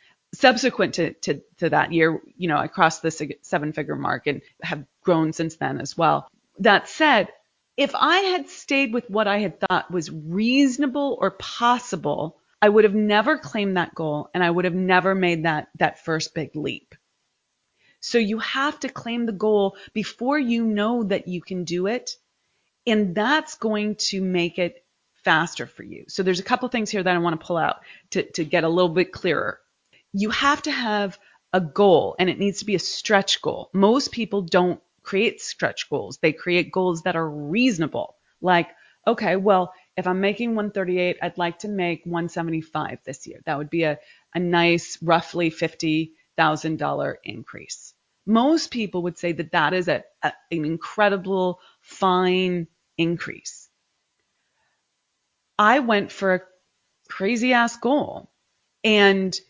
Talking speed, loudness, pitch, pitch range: 170 wpm, -22 LUFS, 185 Hz, 170-220 Hz